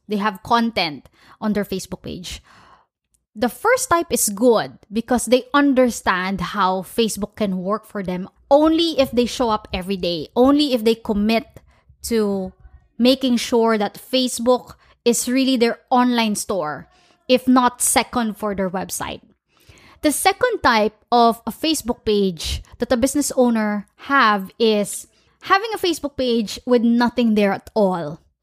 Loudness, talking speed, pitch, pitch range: -19 LUFS, 150 wpm, 235 Hz, 210-255 Hz